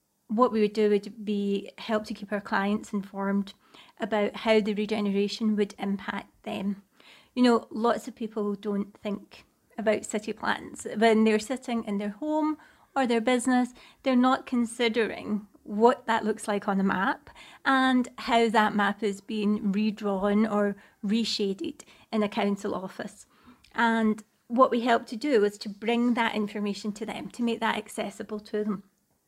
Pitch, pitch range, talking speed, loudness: 215 Hz, 205-235 Hz, 165 wpm, -27 LUFS